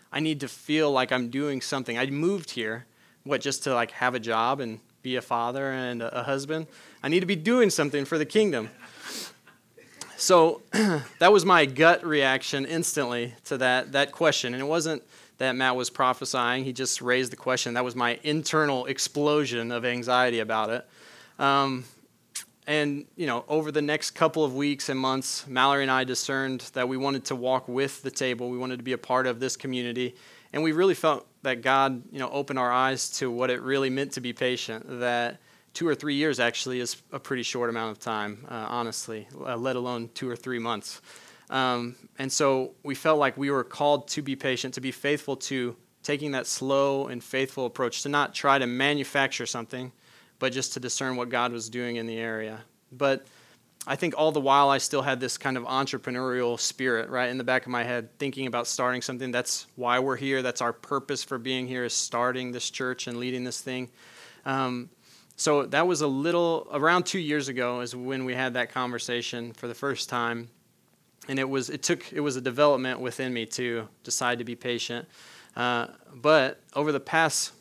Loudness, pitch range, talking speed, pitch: -27 LUFS, 125-140 Hz, 205 wpm, 130 Hz